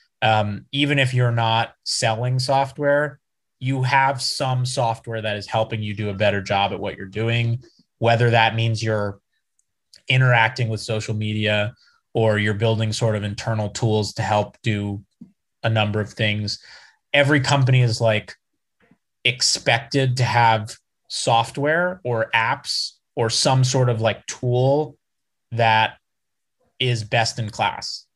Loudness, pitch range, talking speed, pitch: -21 LUFS, 110-130 Hz, 140 wpm, 115 Hz